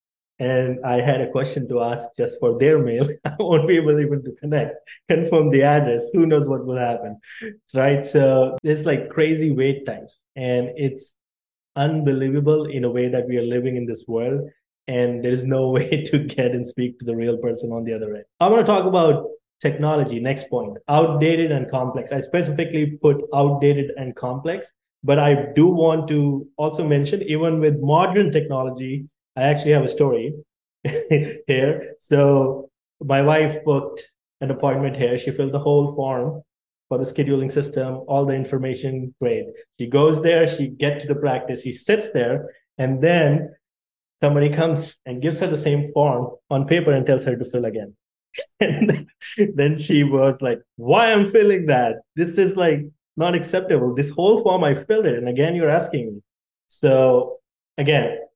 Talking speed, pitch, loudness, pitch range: 180 wpm, 145 Hz, -20 LUFS, 130-155 Hz